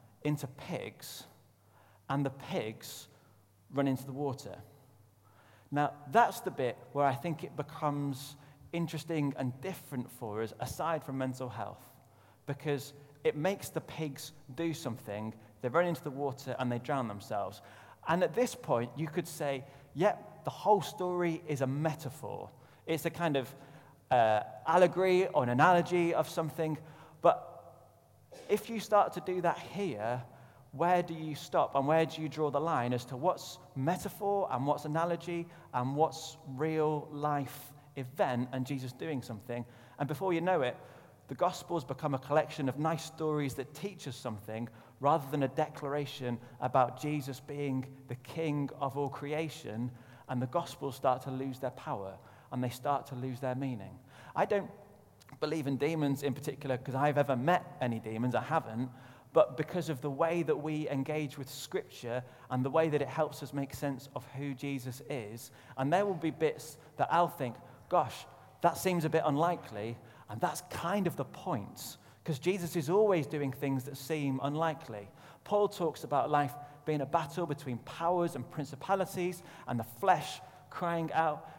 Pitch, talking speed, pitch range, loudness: 145 Hz, 170 wpm, 130-160 Hz, -34 LUFS